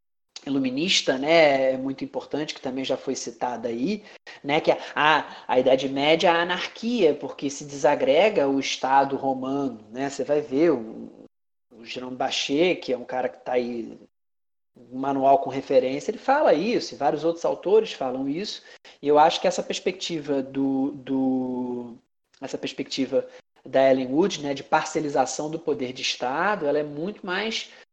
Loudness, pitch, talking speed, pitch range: -24 LUFS, 140 Hz, 165 wpm, 135-175 Hz